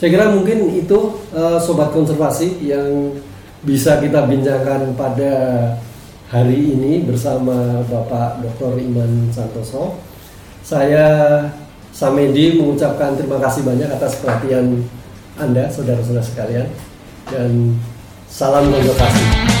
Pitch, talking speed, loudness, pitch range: 135 Hz, 100 wpm, -16 LUFS, 120-145 Hz